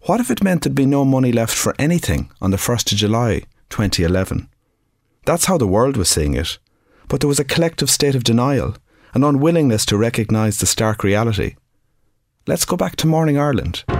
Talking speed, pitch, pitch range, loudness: 195 wpm, 115 Hz, 105-145 Hz, -17 LUFS